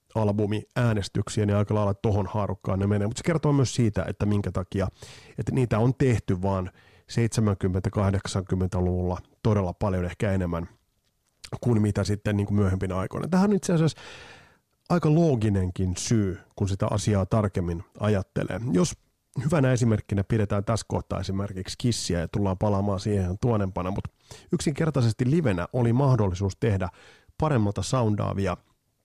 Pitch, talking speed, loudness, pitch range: 105 Hz, 135 wpm, -26 LUFS, 95-120 Hz